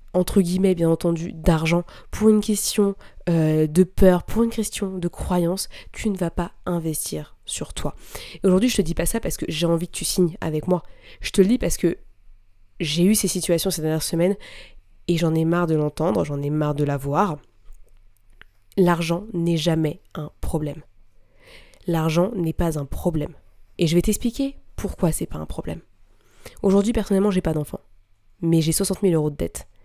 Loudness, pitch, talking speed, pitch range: -22 LUFS, 170 Hz, 190 wpm, 150-185 Hz